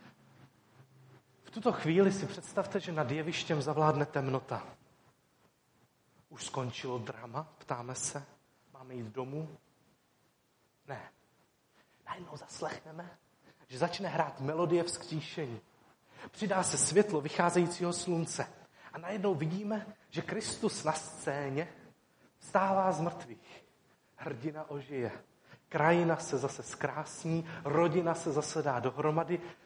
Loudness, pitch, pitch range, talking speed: -34 LUFS, 155 Hz, 140-175 Hz, 105 wpm